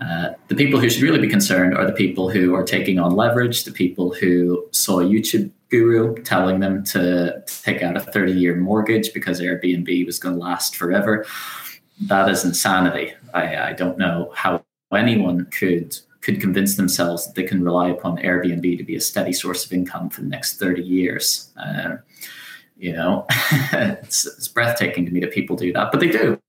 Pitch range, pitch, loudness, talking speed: 90-100 Hz, 90 Hz, -19 LUFS, 190 wpm